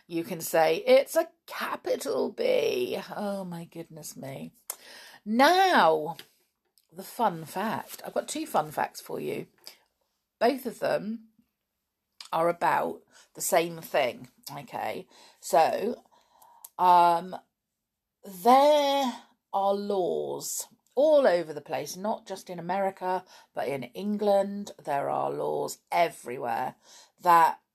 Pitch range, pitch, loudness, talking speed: 175-295 Hz, 205 Hz, -27 LUFS, 110 wpm